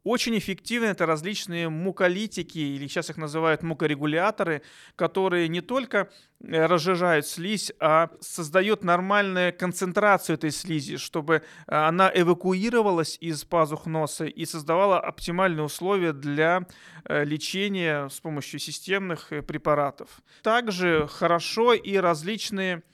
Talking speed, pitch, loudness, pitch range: 105 wpm, 175 Hz, -25 LUFS, 160-190 Hz